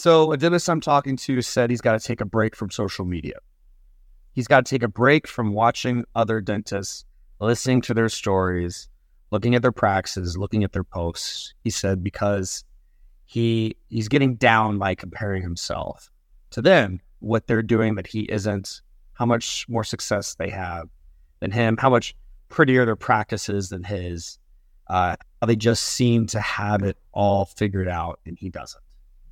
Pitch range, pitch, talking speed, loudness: 90-120 Hz, 105 Hz, 175 wpm, -22 LUFS